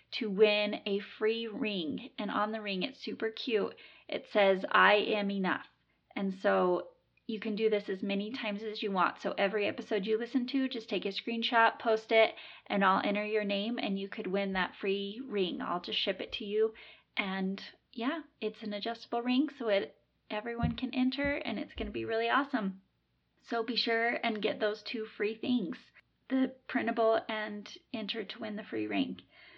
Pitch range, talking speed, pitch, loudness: 205-235 Hz, 195 wpm, 220 Hz, -32 LUFS